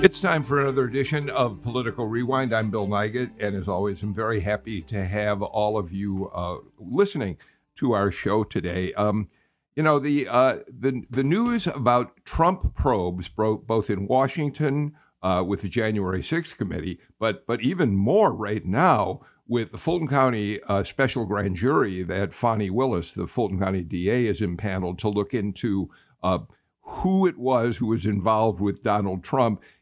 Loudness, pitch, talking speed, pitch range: -25 LUFS, 110 Hz, 170 wpm, 100-130 Hz